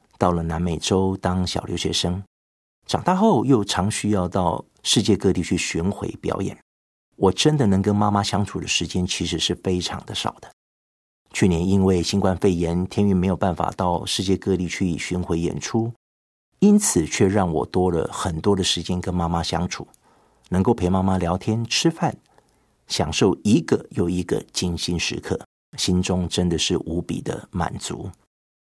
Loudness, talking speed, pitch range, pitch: -22 LUFS, 245 characters per minute, 85-100 Hz, 90 Hz